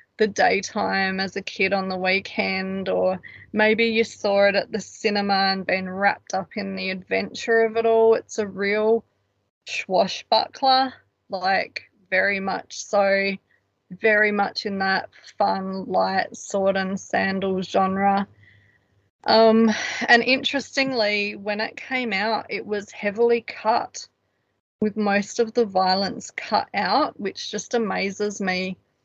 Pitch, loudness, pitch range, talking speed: 200 Hz, -22 LUFS, 190-220 Hz, 135 wpm